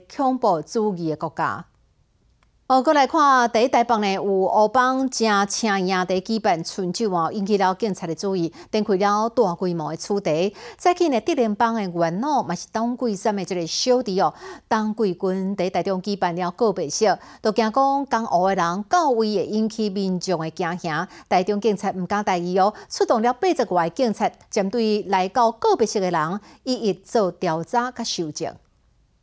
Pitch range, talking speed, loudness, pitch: 185-235 Hz, 265 characters per minute, -22 LUFS, 205 Hz